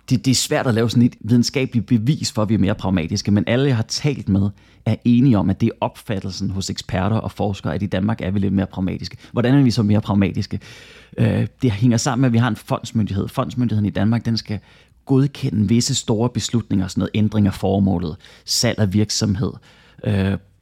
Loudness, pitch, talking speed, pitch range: -19 LUFS, 110 Hz, 215 wpm, 100-120 Hz